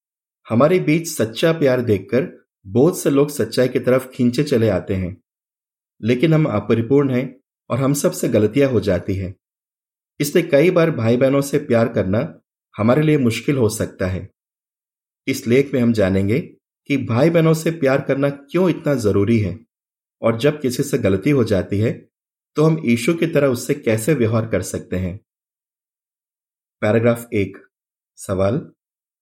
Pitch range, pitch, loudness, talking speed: 105-145 Hz, 125 Hz, -18 LUFS, 160 wpm